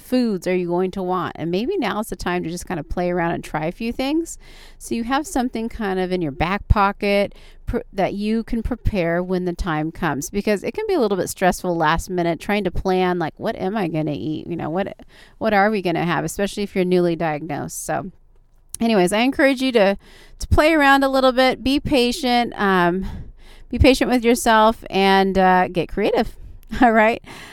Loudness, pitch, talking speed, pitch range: -20 LUFS, 195 Hz, 220 wpm, 175-230 Hz